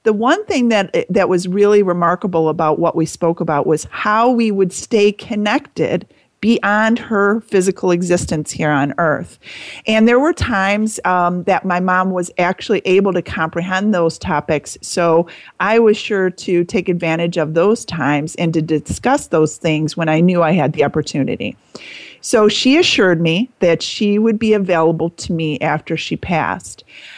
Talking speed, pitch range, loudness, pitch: 170 wpm, 165-210 Hz, -16 LUFS, 180 Hz